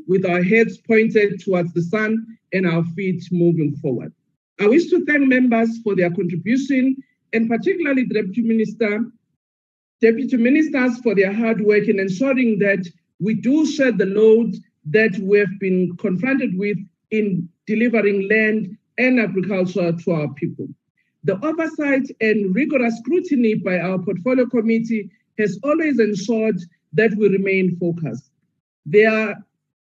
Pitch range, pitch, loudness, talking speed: 185-230 Hz, 210 Hz, -19 LUFS, 145 wpm